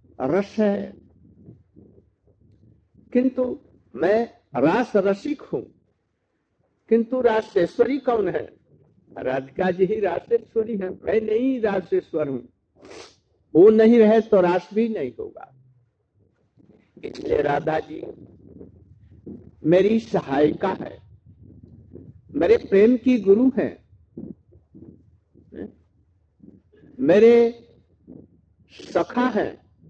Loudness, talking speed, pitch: -21 LUFS, 85 wpm, 195 Hz